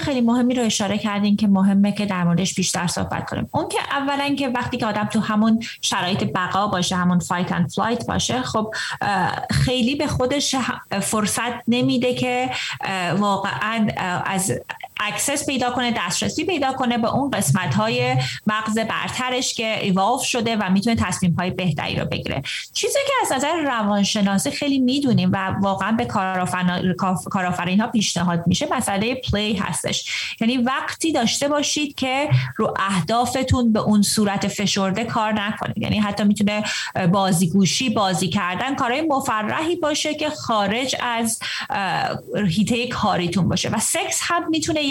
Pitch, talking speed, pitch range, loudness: 215 Hz, 145 wpm, 190-255 Hz, -21 LUFS